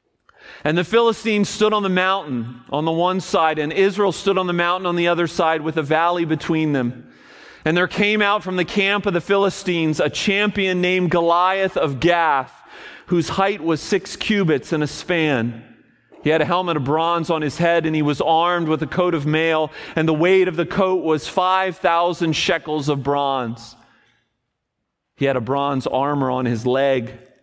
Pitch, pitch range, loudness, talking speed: 170 Hz, 150-185 Hz, -19 LUFS, 195 wpm